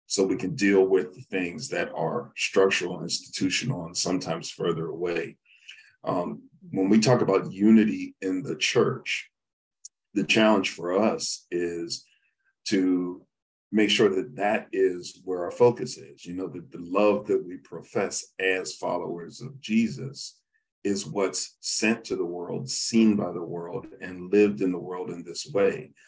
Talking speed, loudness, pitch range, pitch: 160 wpm, -26 LUFS, 90-110 Hz, 95 Hz